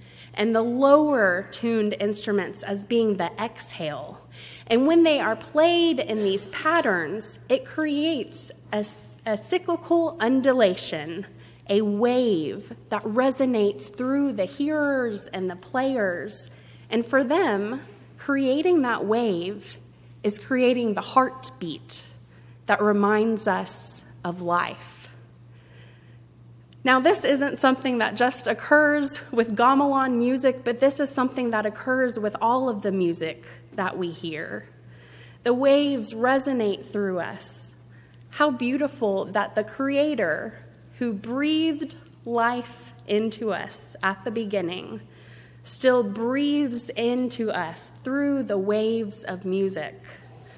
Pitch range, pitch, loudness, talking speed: 185-265 Hz, 220 Hz, -24 LUFS, 115 wpm